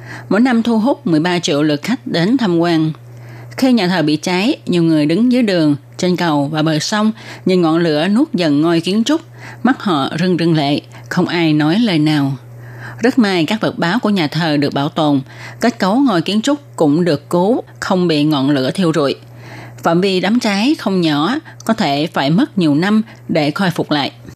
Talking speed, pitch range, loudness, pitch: 210 wpm, 150-215 Hz, -15 LUFS, 170 Hz